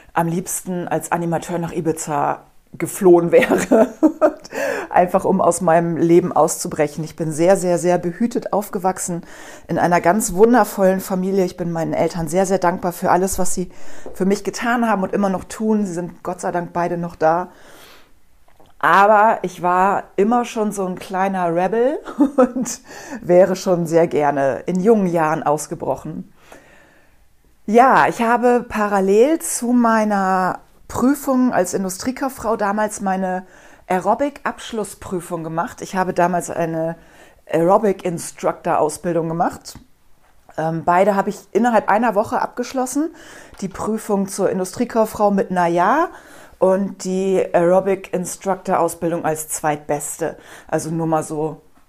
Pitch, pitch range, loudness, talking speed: 185 Hz, 170-215 Hz, -18 LUFS, 130 wpm